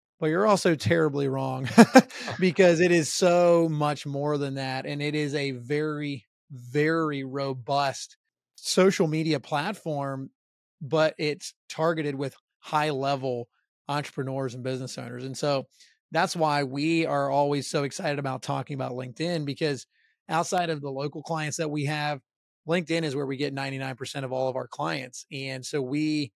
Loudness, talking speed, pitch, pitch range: -26 LUFS, 160 wpm, 145 Hz, 135-160 Hz